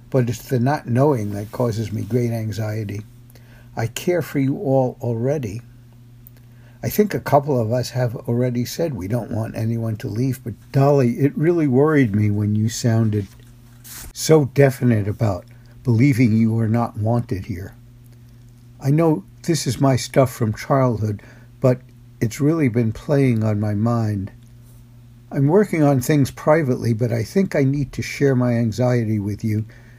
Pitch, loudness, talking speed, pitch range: 120 Hz, -20 LUFS, 160 wpm, 115-135 Hz